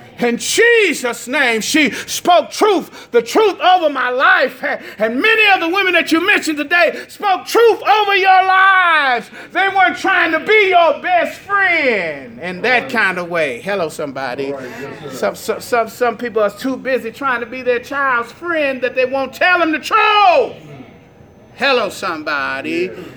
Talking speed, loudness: 165 wpm, -14 LUFS